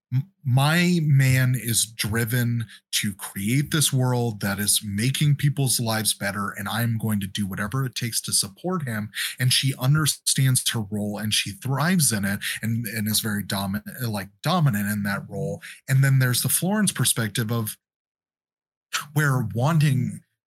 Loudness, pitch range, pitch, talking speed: -23 LUFS, 105-135 Hz, 120 Hz, 160 wpm